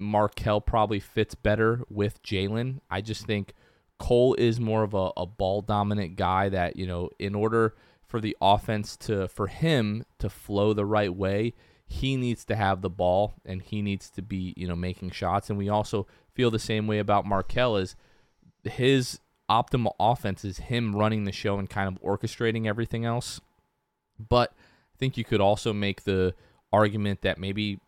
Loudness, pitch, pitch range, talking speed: -27 LUFS, 105 Hz, 95-115 Hz, 180 wpm